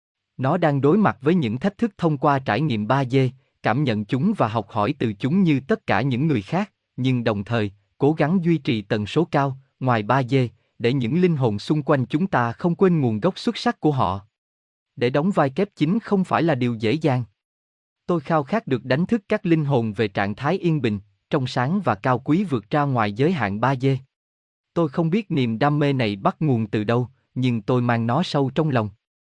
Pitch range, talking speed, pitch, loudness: 115-160 Hz, 225 wpm, 135 Hz, -22 LUFS